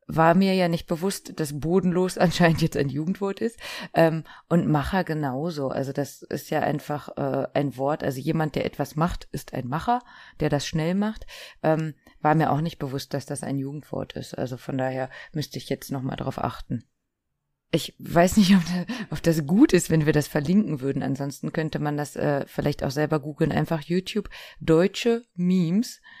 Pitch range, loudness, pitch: 145-180 Hz, -25 LUFS, 160 Hz